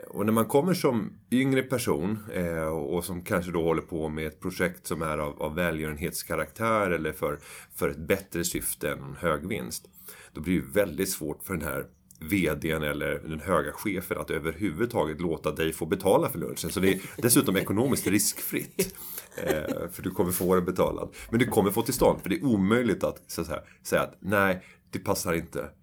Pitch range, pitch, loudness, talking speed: 80-100 Hz, 85 Hz, -28 LUFS, 190 wpm